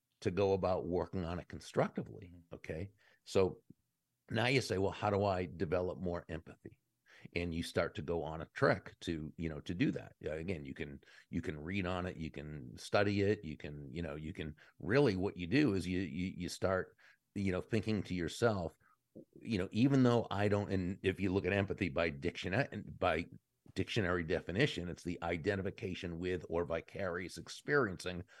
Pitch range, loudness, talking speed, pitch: 85-100 Hz, -37 LUFS, 190 wpm, 90 Hz